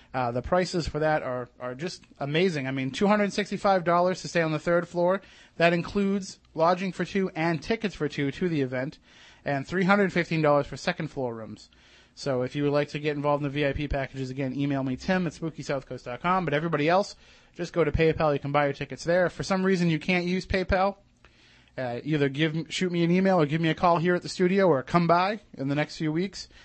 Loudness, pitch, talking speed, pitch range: -26 LUFS, 160 Hz, 220 wpm, 140-180 Hz